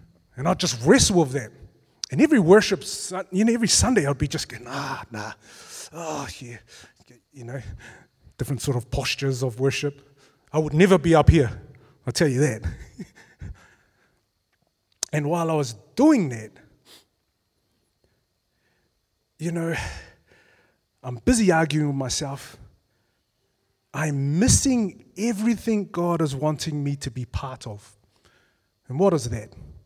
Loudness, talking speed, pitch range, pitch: -22 LUFS, 135 wpm, 115-170 Hz, 140 Hz